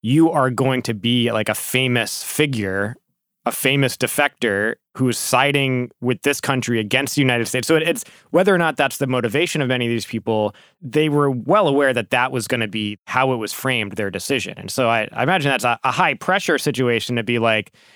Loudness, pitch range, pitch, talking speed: -19 LUFS, 115-140 Hz, 125 Hz, 215 wpm